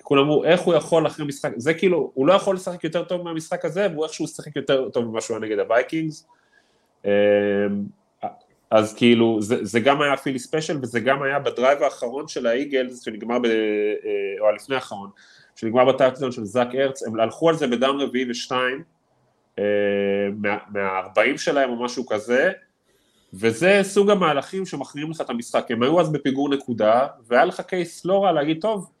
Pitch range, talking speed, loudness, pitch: 115-160 Hz, 175 wpm, -21 LUFS, 135 Hz